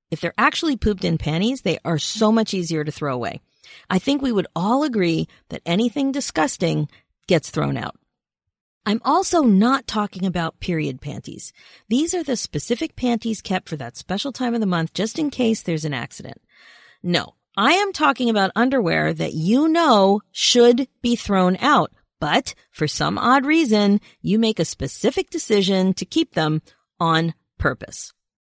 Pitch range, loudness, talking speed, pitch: 170-255 Hz, -20 LUFS, 170 wpm, 210 Hz